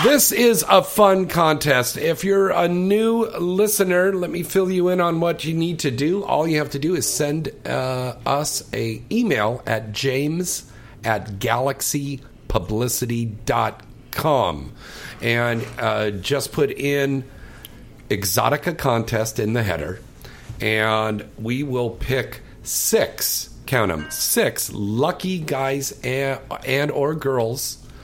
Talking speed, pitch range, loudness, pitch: 130 wpm, 115-165 Hz, -21 LUFS, 135 Hz